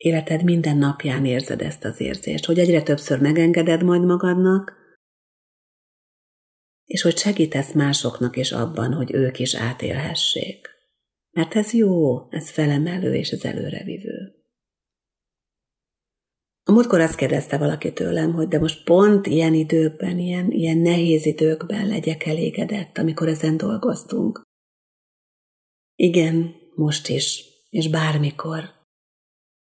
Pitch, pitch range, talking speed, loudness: 160 Hz, 155-180 Hz, 115 wpm, -20 LUFS